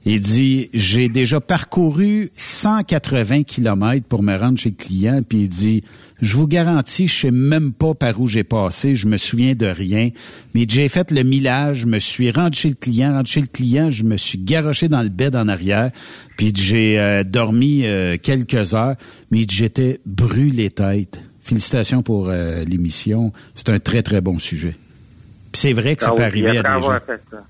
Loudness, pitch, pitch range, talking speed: -17 LUFS, 120 Hz, 105-135 Hz, 205 wpm